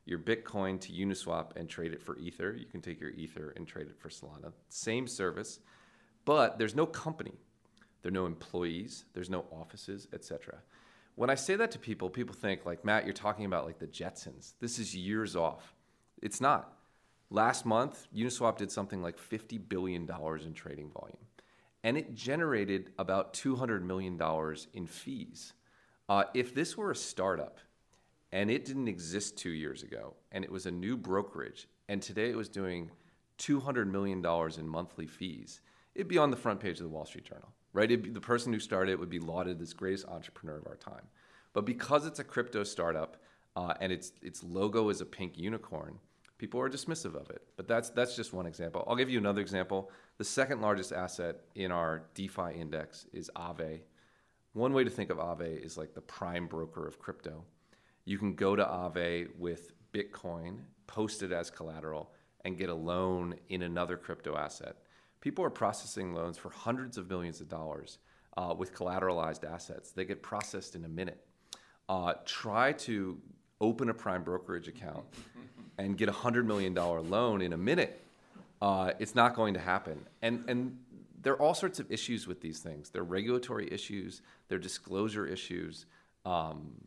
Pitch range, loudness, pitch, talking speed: 85-110 Hz, -36 LUFS, 95 Hz, 185 wpm